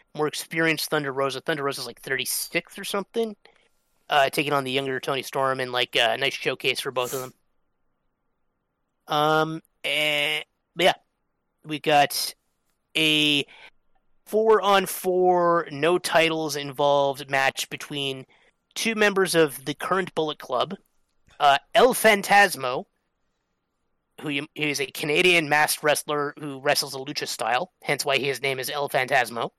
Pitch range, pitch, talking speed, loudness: 140-175 Hz, 150 Hz, 145 wpm, -23 LUFS